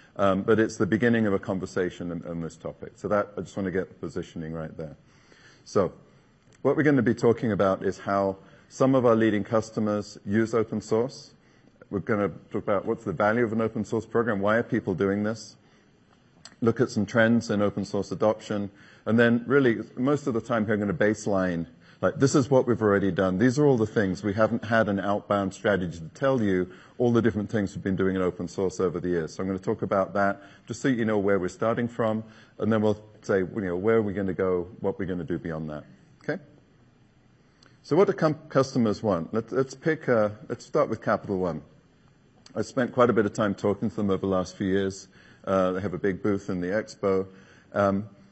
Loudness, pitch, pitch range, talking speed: -26 LUFS, 105 Hz, 95-115 Hz, 225 wpm